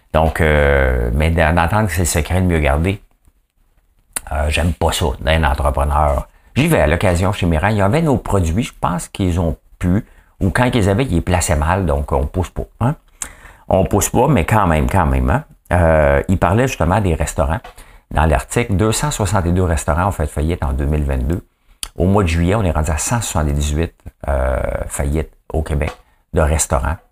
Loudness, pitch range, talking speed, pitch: -17 LUFS, 75-95 Hz, 190 wpm, 80 Hz